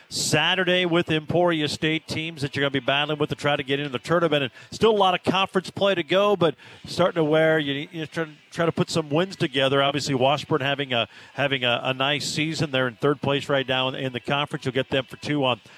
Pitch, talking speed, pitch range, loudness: 150 Hz, 245 wpm, 140-165 Hz, -23 LUFS